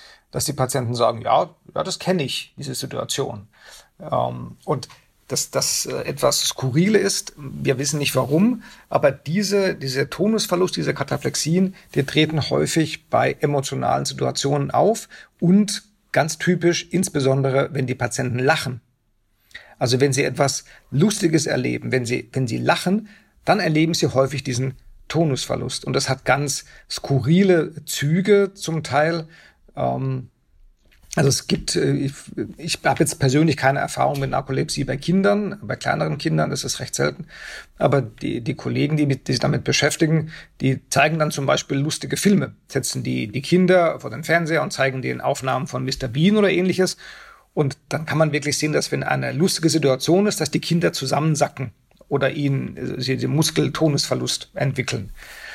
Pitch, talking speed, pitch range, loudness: 145 Hz, 155 wpm, 130-170 Hz, -21 LUFS